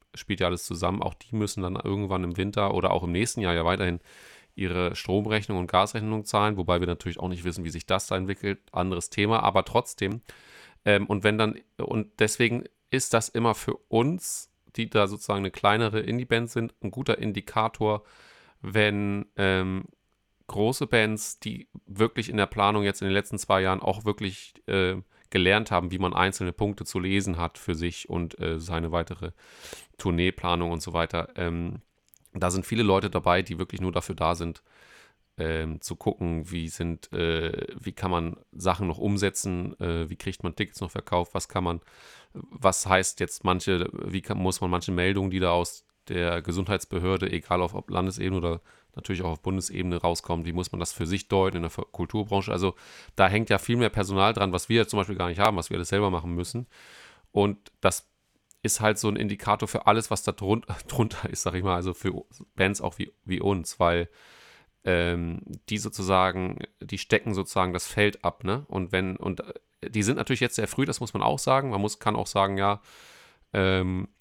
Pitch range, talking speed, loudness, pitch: 90-105 Hz, 195 wpm, -27 LUFS, 95 Hz